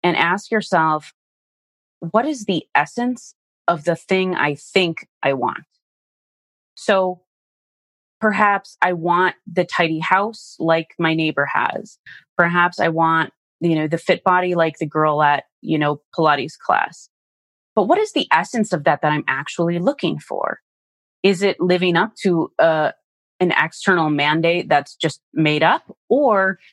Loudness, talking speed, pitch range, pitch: -19 LUFS, 155 wpm, 155-190 Hz, 170 Hz